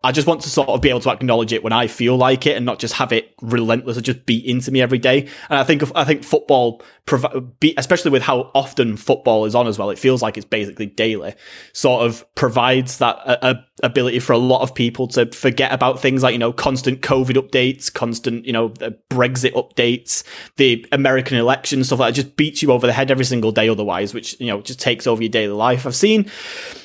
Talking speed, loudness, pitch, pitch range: 240 wpm, -17 LUFS, 130 Hz, 120-135 Hz